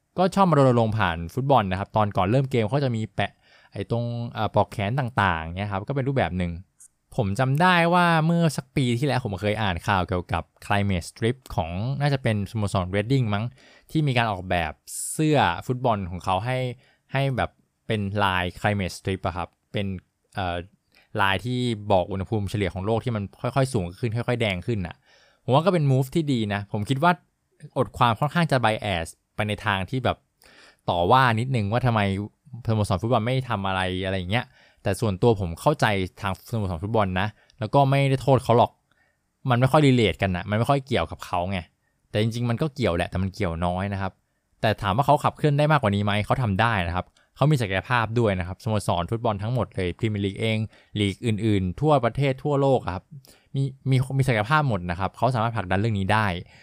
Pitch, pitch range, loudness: 110 Hz, 95-130 Hz, -24 LUFS